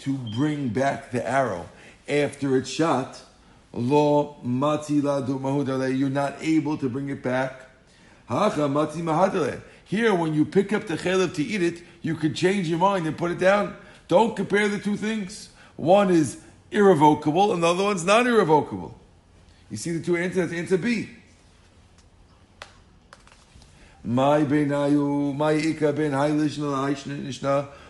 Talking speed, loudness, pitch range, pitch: 115 wpm, -23 LUFS, 135-175 Hz, 150 Hz